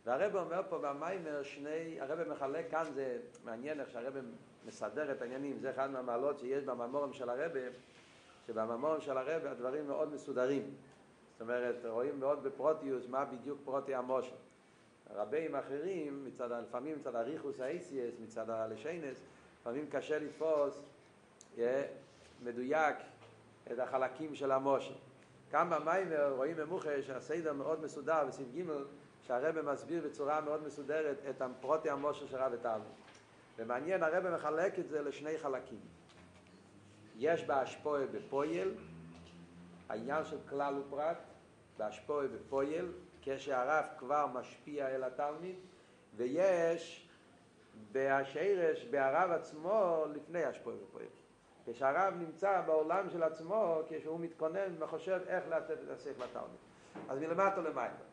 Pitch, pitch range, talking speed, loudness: 145 Hz, 130-160 Hz, 120 wpm, -38 LUFS